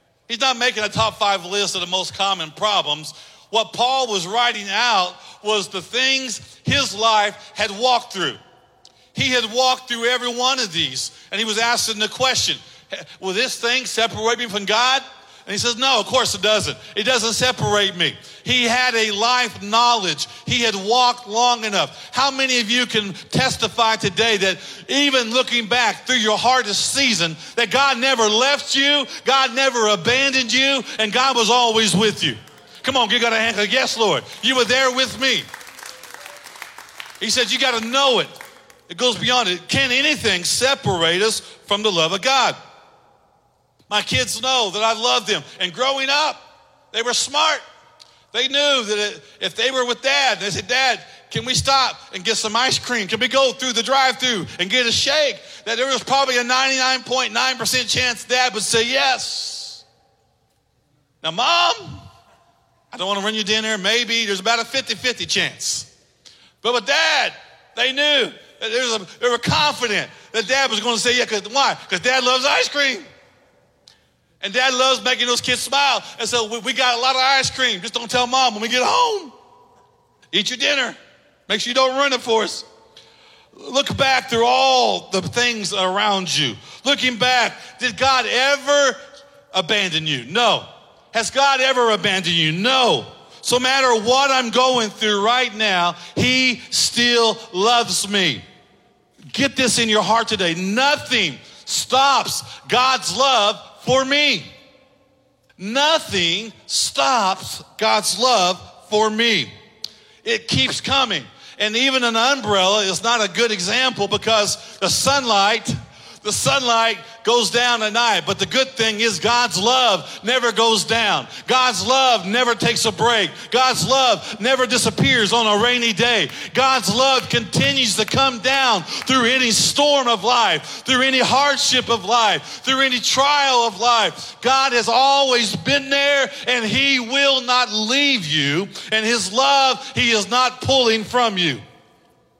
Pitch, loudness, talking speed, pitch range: 240 Hz, -17 LUFS, 170 wpm, 215-260 Hz